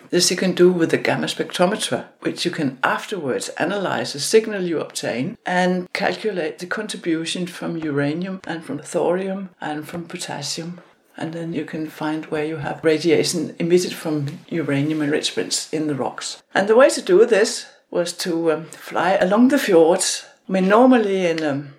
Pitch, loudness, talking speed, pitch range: 170 Hz, -20 LUFS, 175 wpm, 155-190 Hz